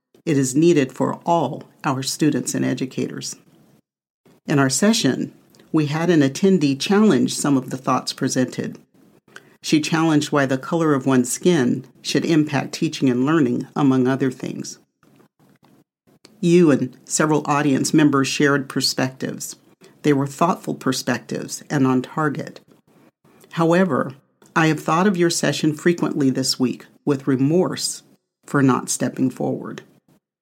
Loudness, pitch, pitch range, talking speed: -20 LUFS, 145 Hz, 135-160 Hz, 135 wpm